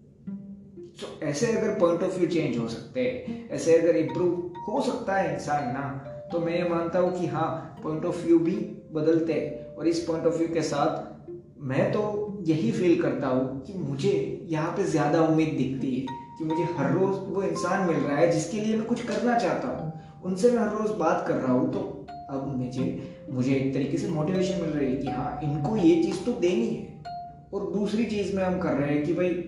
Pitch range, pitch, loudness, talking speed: 150-185 Hz, 170 Hz, -27 LUFS, 215 wpm